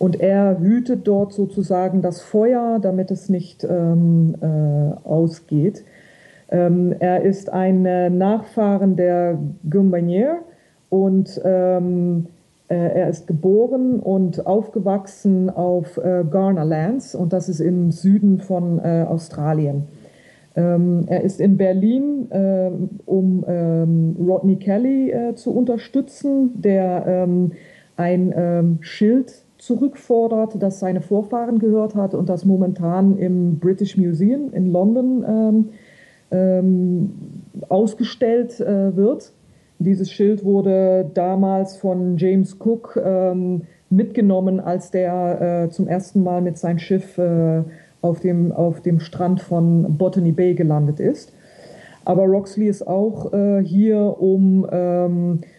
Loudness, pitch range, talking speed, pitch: -18 LUFS, 175-200 Hz, 120 wpm, 185 Hz